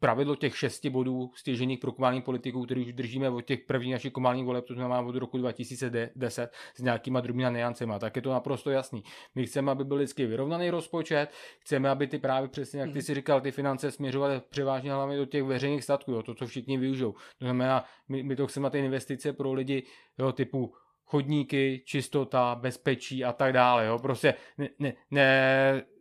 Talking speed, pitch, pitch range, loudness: 195 wpm, 135 Hz, 125-140 Hz, -30 LUFS